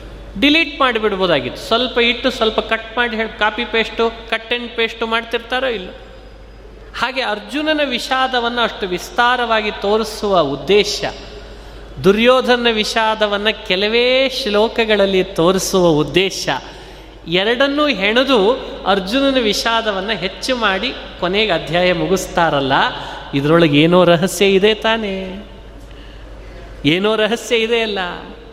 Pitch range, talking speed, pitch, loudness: 190-240 Hz, 95 wpm, 220 Hz, -16 LUFS